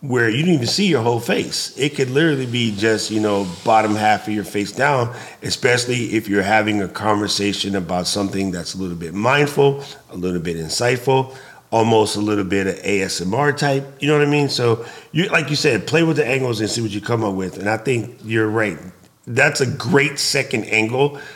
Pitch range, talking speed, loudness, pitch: 100-140 Hz, 215 wpm, -18 LUFS, 115 Hz